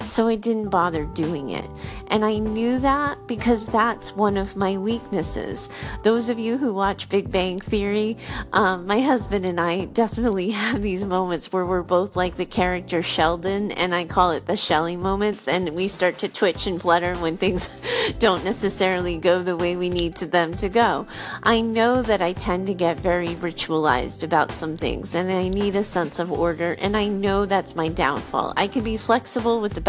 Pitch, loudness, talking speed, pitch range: 190 Hz, -22 LUFS, 195 wpm, 175-215 Hz